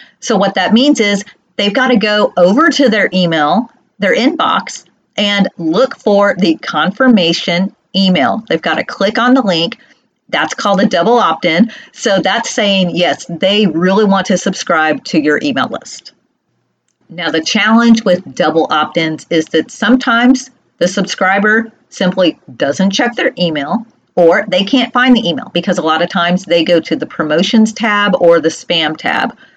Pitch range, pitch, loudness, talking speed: 170-235 Hz, 195 Hz, -12 LUFS, 175 wpm